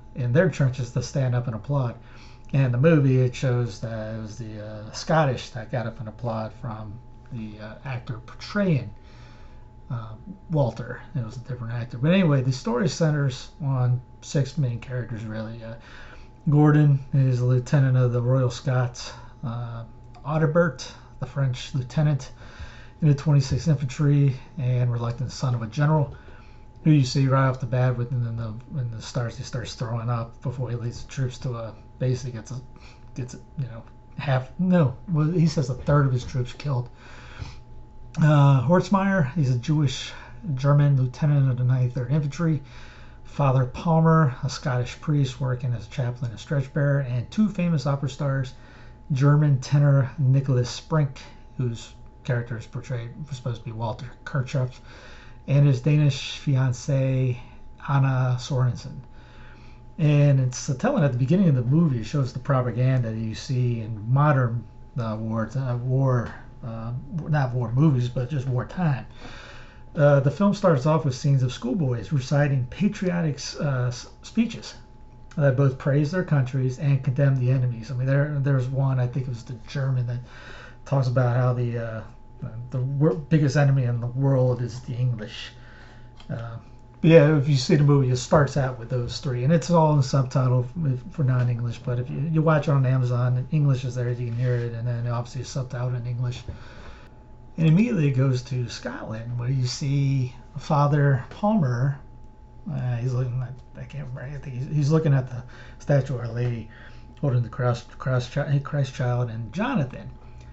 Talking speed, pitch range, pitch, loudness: 170 wpm, 120-140 Hz, 130 Hz, -24 LUFS